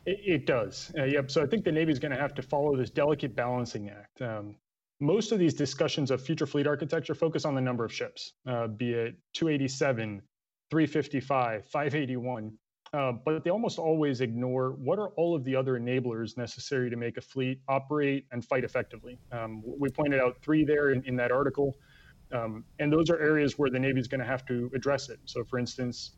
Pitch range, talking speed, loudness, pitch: 120-150 Hz, 205 wpm, -30 LUFS, 135 Hz